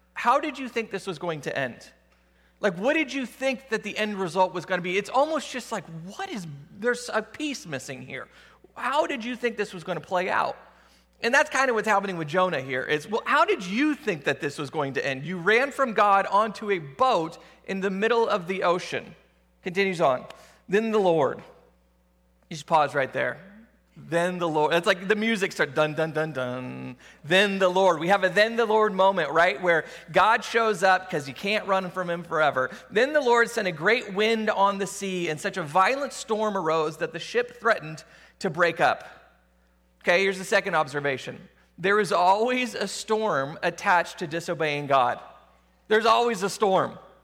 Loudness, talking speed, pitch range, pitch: -25 LUFS, 205 wpm, 160-215 Hz, 190 Hz